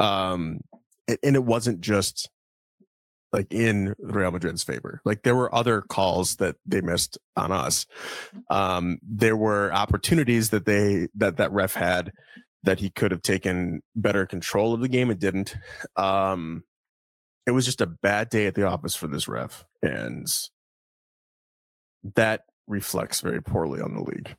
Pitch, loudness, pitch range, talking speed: 100 Hz, -25 LUFS, 90-110 Hz, 155 wpm